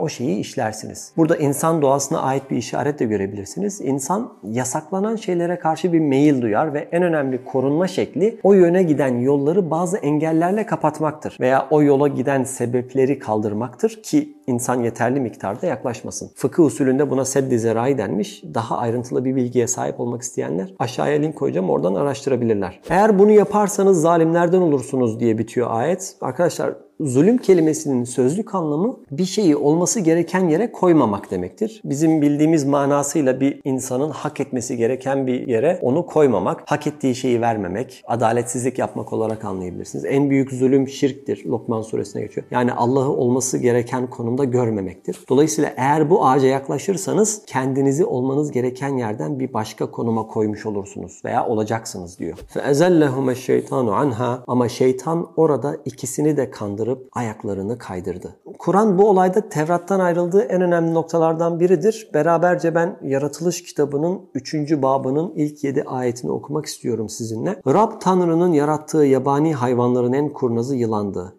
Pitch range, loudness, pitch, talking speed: 125-165 Hz, -19 LUFS, 140 Hz, 140 wpm